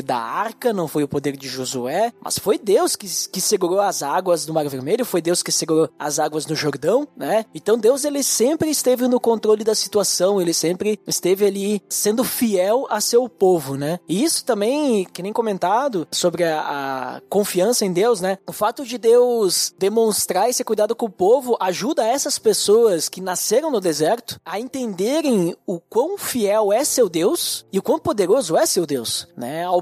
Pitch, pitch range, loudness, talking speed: 205 Hz, 175-245 Hz, -19 LUFS, 190 wpm